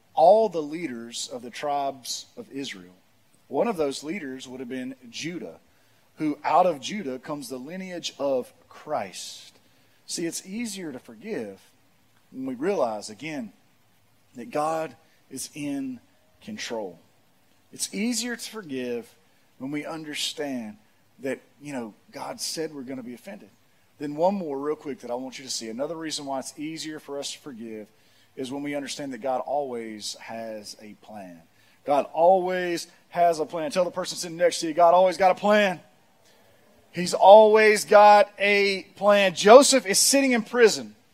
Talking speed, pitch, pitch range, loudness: 165 wpm, 155 Hz, 130-195 Hz, -23 LUFS